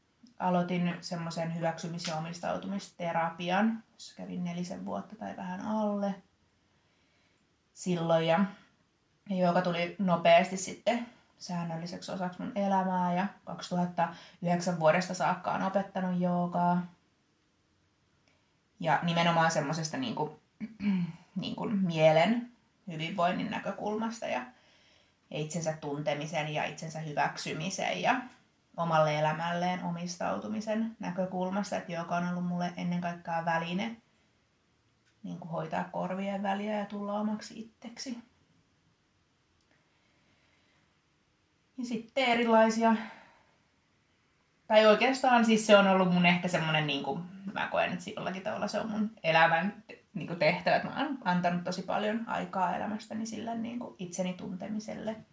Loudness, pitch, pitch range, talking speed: -31 LUFS, 180 Hz, 170-215 Hz, 110 wpm